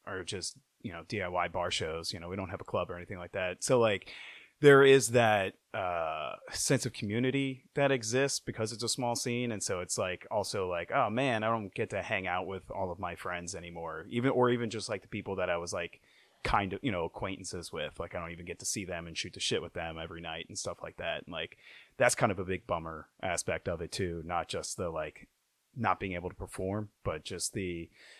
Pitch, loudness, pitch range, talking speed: 100 Hz, -32 LUFS, 90-120 Hz, 245 wpm